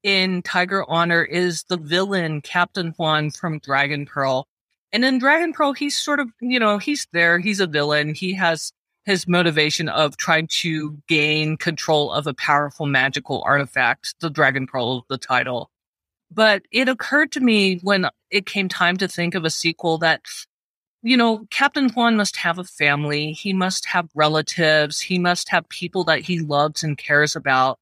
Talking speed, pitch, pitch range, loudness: 175 wpm, 170 Hz, 150-195 Hz, -20 LUFS